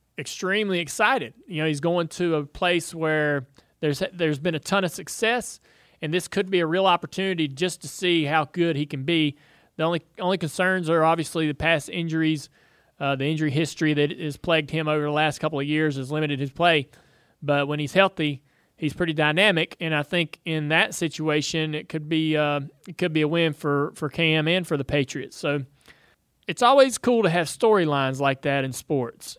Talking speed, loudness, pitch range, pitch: 200 wpm, -24 LUFS, 150-175 Hz, 160 Hz